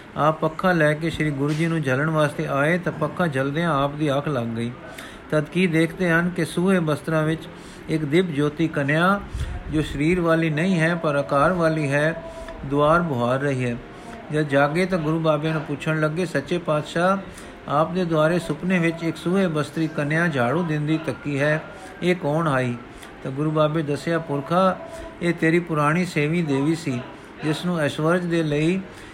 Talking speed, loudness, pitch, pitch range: 175 wpm, -22 LUFS, 155 Hz, 145-170 Hz